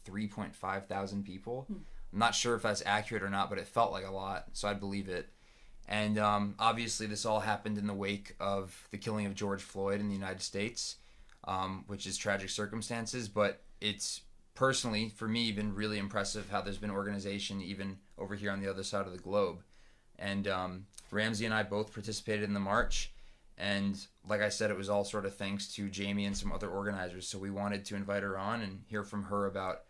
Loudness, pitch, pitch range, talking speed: -36 LUFS, 100 Hz, 100-105 Hz, 210 wpm